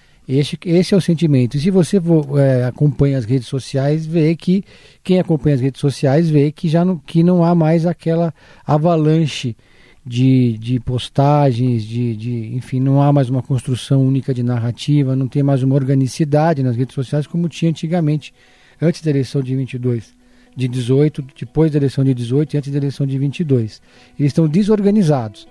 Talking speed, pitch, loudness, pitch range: 180 wpm, 140 Hz, -16 LUFS, 130-165 Hz